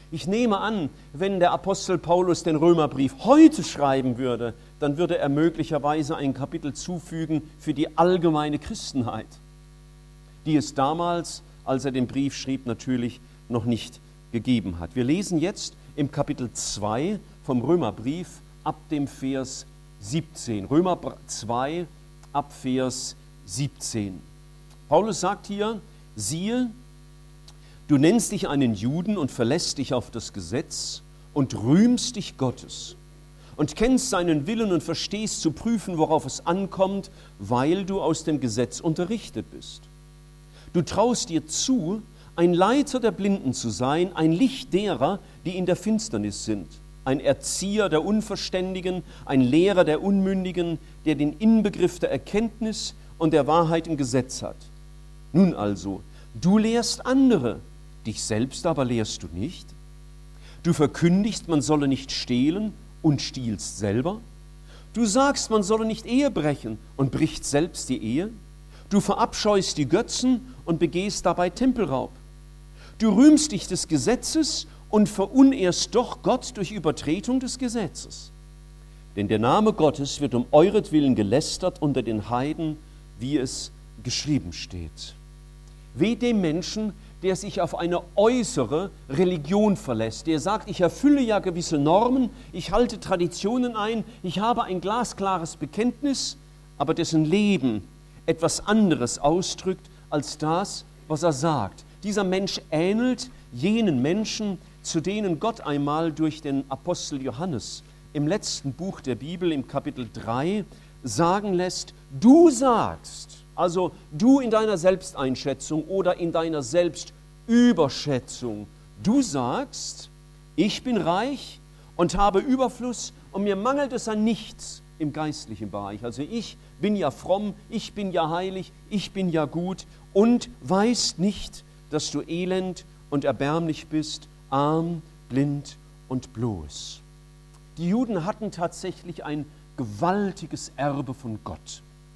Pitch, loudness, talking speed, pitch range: 155 Hz, -24 LUFS, 135 wpm, 145-190 Hz